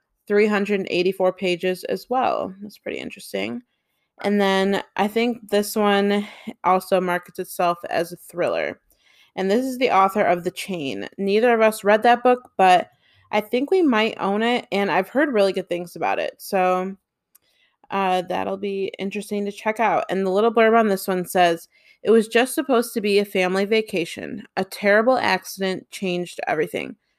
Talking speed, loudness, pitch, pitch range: 170 wpm, -21 LUFS, 200 Hz, 185-225 Hz